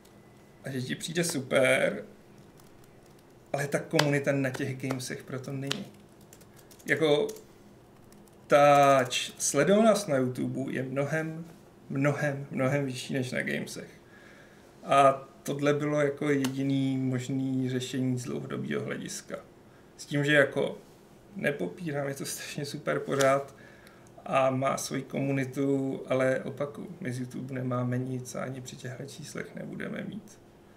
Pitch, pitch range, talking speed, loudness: 140 Hz, 130-150 Hz, 130 wpm, -29 LUFS